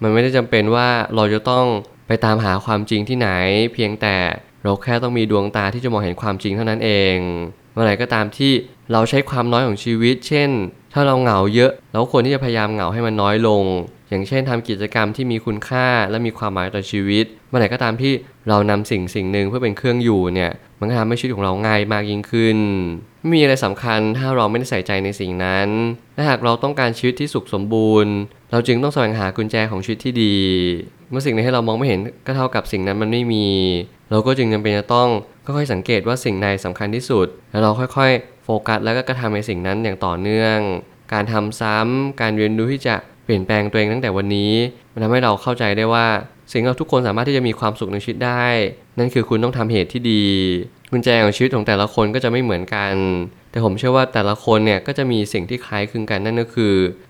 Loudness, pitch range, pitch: -18 LUFS, 105-125 Hz, 110 Hz